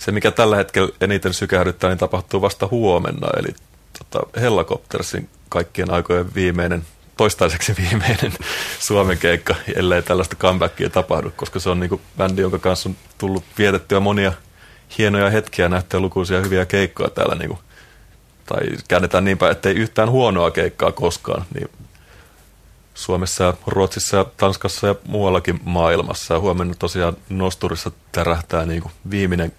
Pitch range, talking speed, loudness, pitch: 90-100 Hz, 140 wpm, -19 LUFS, 95 Hz